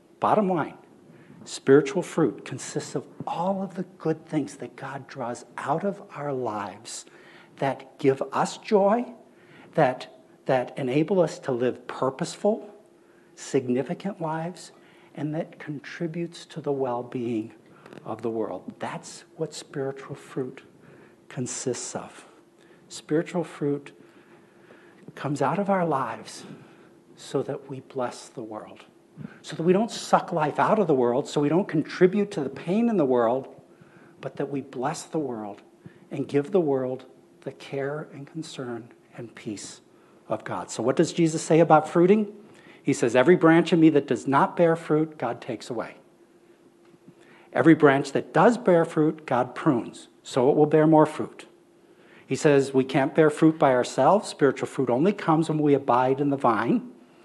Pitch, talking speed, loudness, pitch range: 155 Hz, 160 wpm, -25 LUFS, 135-175 Hz